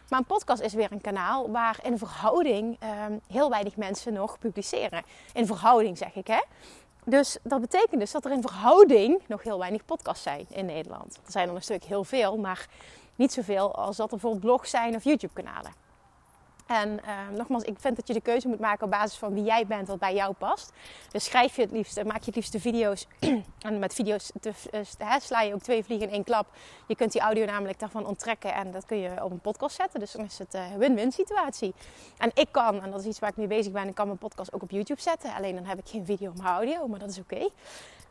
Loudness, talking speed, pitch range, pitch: -28 LUFS, 240 wpm, 205-240 Hz, 215 Hz